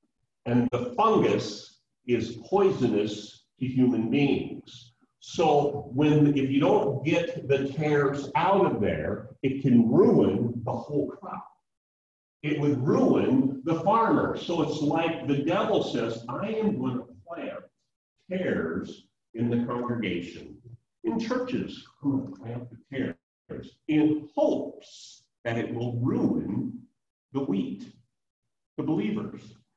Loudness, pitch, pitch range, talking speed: -26 LUFS, 135 Hz, 120-150 Hz, 120 wpm